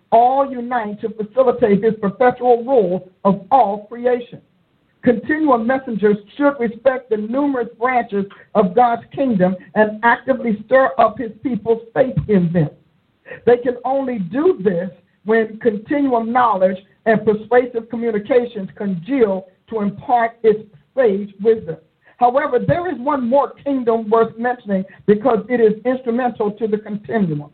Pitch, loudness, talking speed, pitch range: 230 Hz, -18 LUFS, 135 wpm, 205-245 Hz